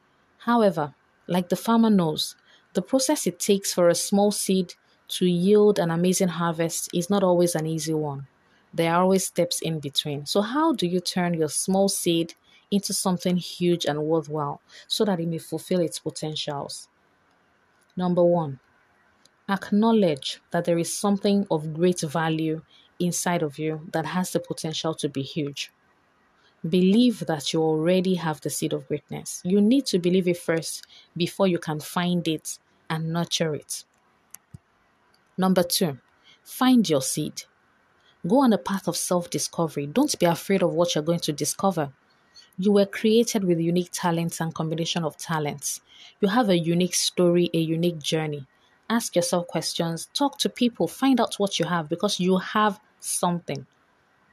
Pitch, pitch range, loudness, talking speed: 175 Hz, 160-195 Hz, -24 LUFS, 160 wpm